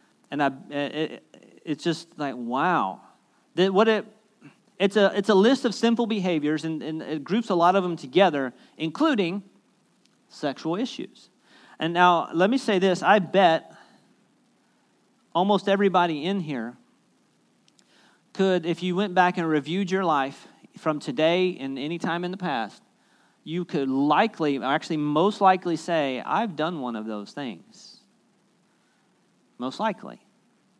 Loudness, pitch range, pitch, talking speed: -24 LUFS, 155-200 Hz, 180 Hz, 145 wpm